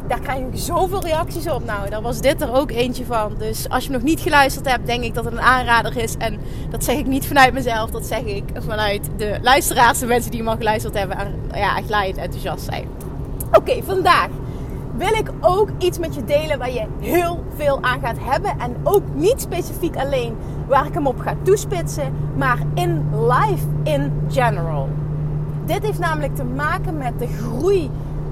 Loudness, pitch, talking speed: -20 LUFS, 170 Hz, 205 wpm